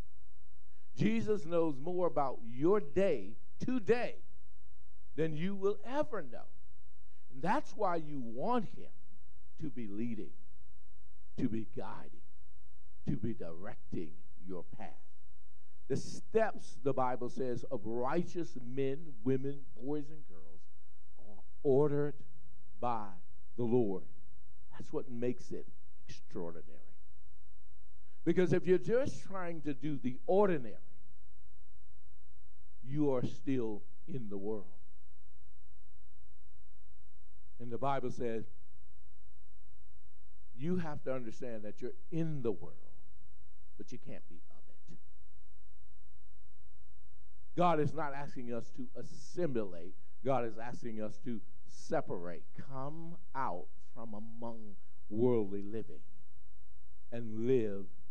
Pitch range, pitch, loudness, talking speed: 90-140 Hz, 105 Hz, -38 LUFS, 110 wpm